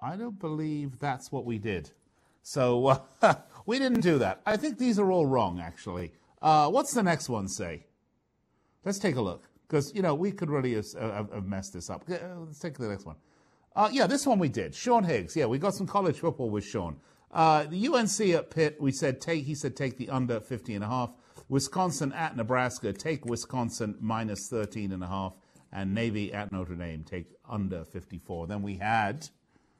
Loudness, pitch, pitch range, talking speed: -30 LUFS, 130 Hz, 105-165 Hz, 205 wpm